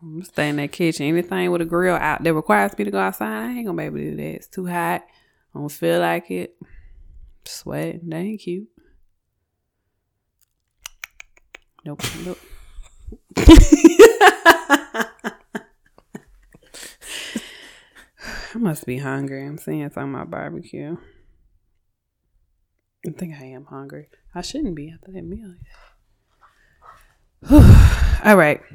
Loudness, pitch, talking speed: -17 LUFS, 155 Hz, 125 wpm